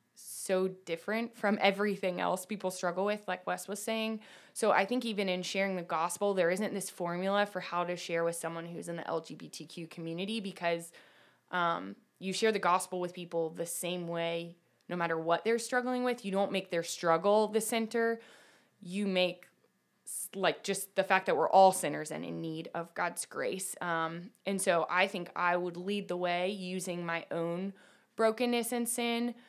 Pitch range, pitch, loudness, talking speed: 170-205 Hz, 185 Hz, -33 LUFS, 185 wpm